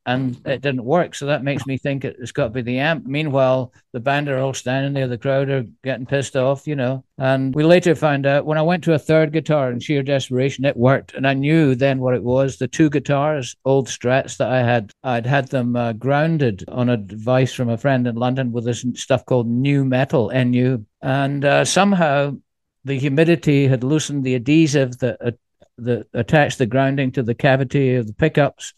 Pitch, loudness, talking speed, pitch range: 135 Hz, -19 LUFS, 215 wpm, 125-145 Hz